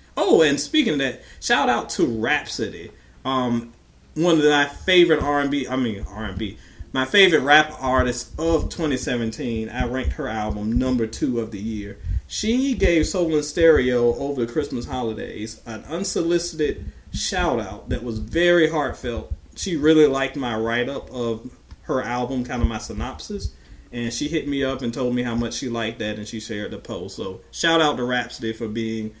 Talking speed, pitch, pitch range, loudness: 175 wpm, 125 Hz, 110-150 Hz, -22 LUFS